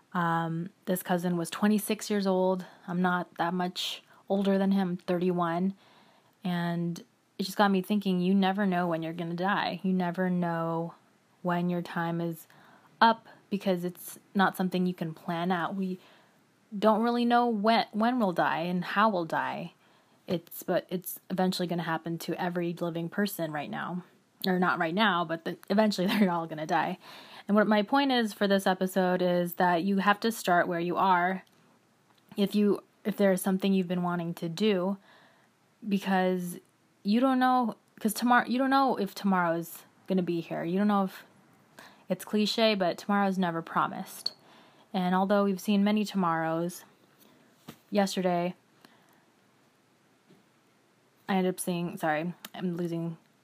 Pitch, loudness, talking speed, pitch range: 185 Hz, -29 LUFS, 165 wpm, 175-205 Hz